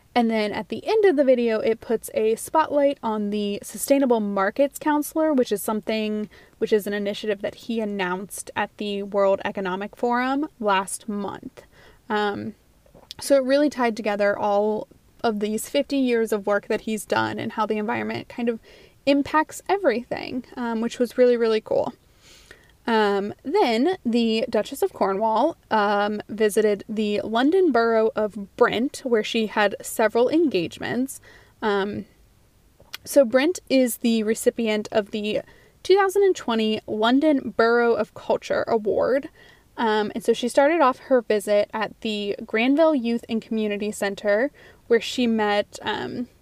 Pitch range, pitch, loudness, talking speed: 210-265 Hz, 225 Hz, -23 LUFS, 150 wpm